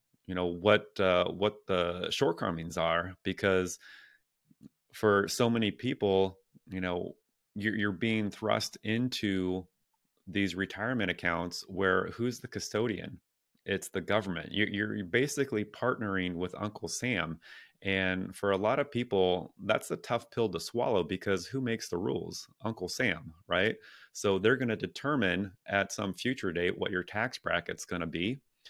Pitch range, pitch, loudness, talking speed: 90-110 Hz, 100 Hz, -32 LUFS, 155 wpm